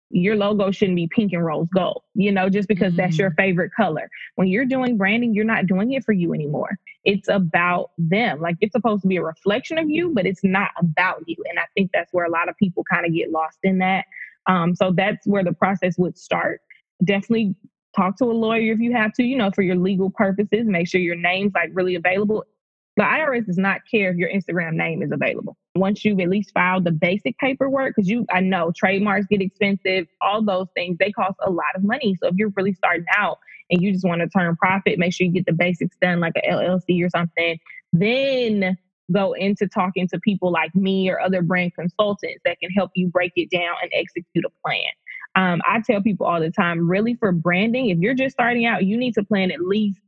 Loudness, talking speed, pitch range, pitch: -20 LUFS, 230 wpm, 180-210 Hz, 190 Hz